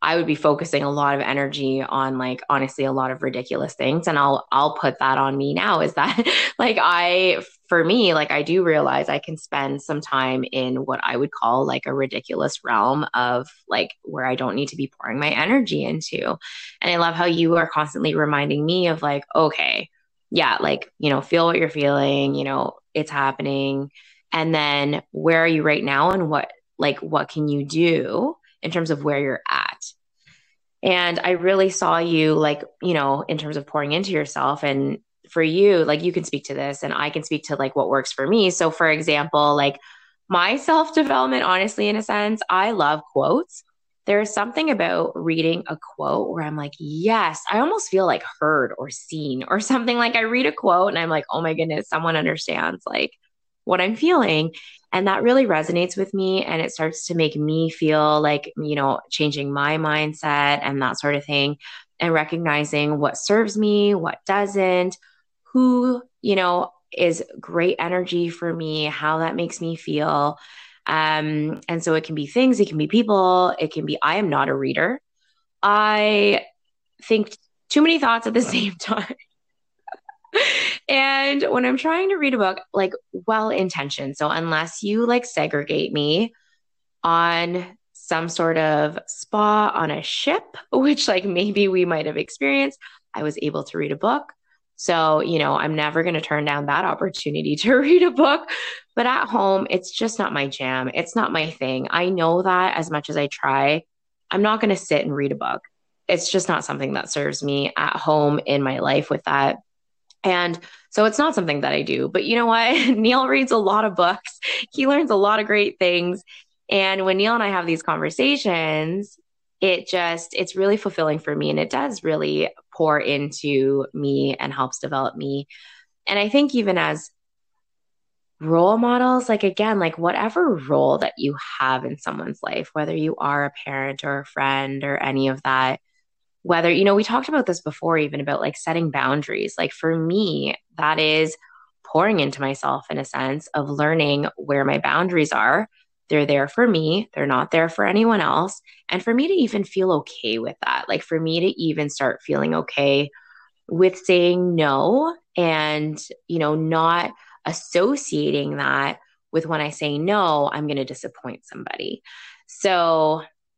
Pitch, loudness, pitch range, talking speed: 165 Hz, -21 LUFS, 145-200 Hz, 190 wpm